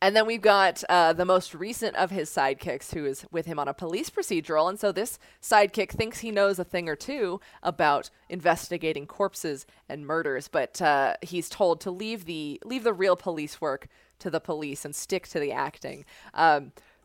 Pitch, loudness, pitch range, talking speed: 180 Hz, -27 LUFS, 160-205 Hz, 195 wpm